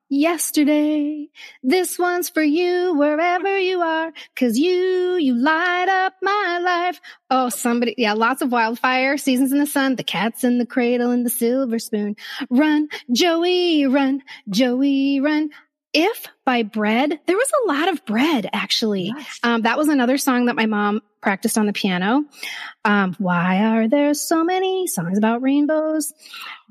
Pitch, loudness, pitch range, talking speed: 280 Hz, -19 LUFS, 240-330 Hz, 155 wpm